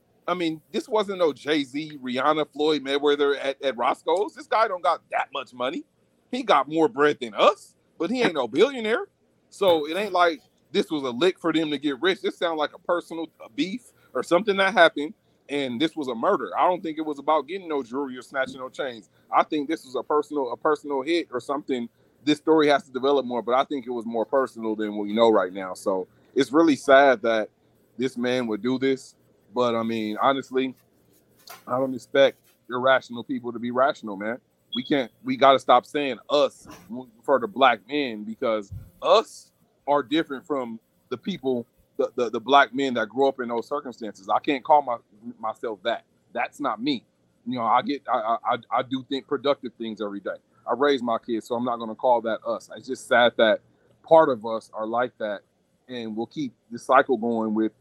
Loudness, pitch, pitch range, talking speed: -24 LUFS, 135 Hz, 120-155 Hz, 210 wpm